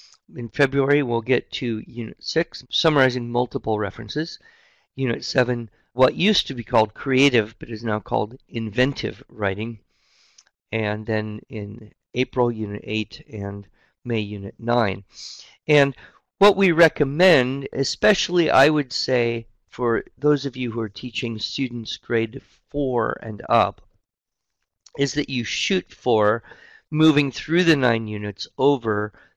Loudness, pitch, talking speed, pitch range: -22 LUFS, 120 Hz, 135 wpm, 110-140 Hz